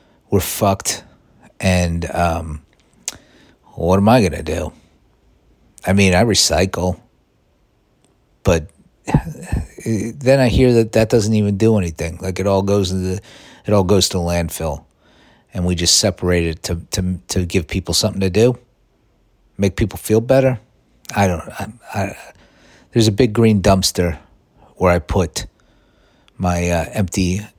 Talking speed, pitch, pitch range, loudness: 145 wpm, 95 Hz, 85-110 Hz, -17 LUFS